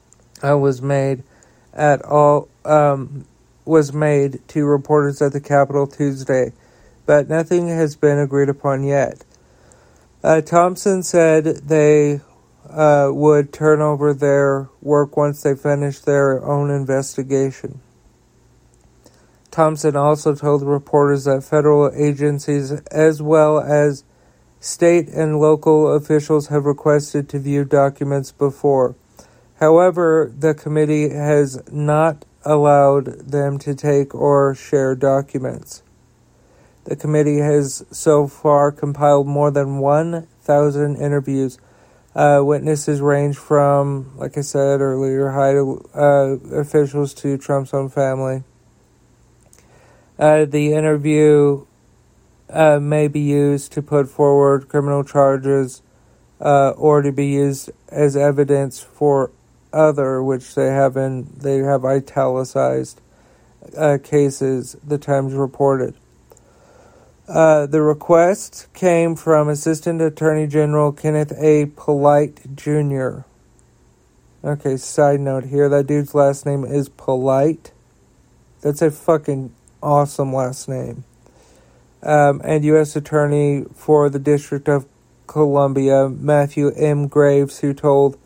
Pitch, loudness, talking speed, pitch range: 145 Hz, -17 LUFS, 115 wpm, 140-150 Hz